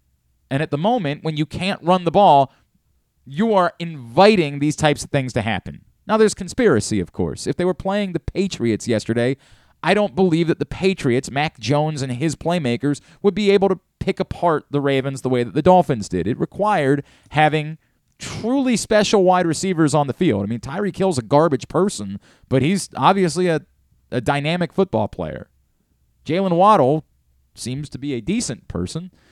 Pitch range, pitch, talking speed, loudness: 130-185 Hz, 155 Hz, 180 wpm, -19 LUFS